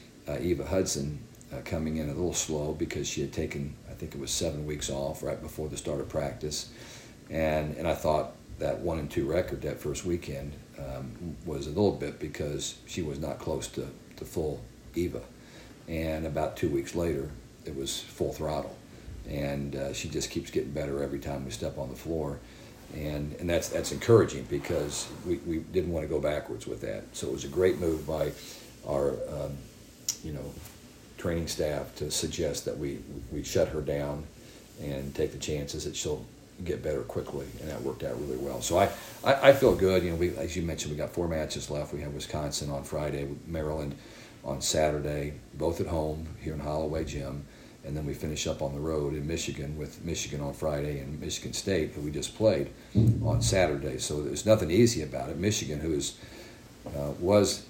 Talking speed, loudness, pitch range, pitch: 200 wpm, -31 LUFS, 70-85 Hz, 75 Hz